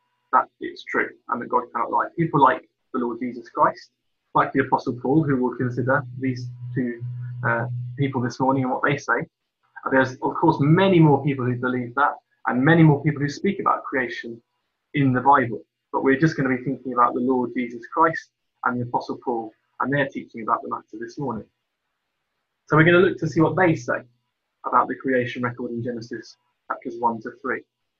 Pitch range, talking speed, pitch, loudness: 125-155 Hz, 205 wpm, 130 Hz, -22 LUFS